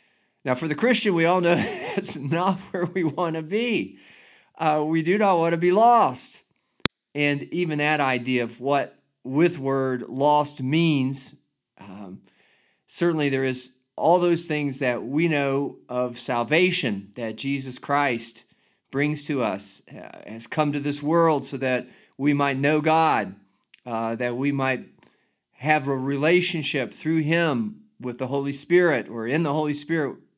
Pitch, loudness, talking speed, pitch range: 145 Hz, -23 LUFS, 155 wpm, 130-170 Hz